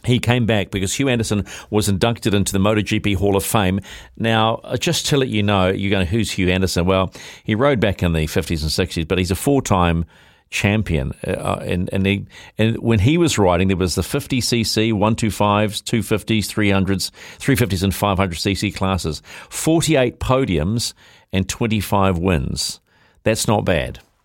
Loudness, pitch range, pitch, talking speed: -19 LUFS, 95-115 Hz, 100 Hz, 180 wpm